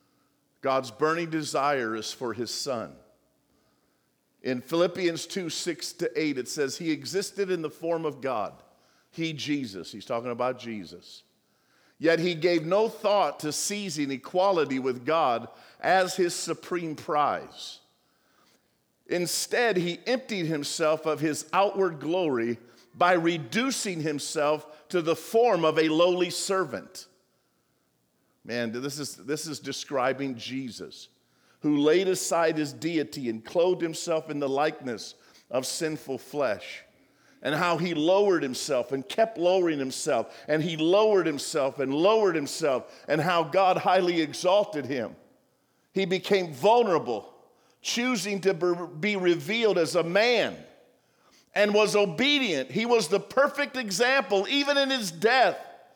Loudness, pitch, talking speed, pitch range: -26 LUFS, 165 Hz, 135 wpm, 145-190 Hz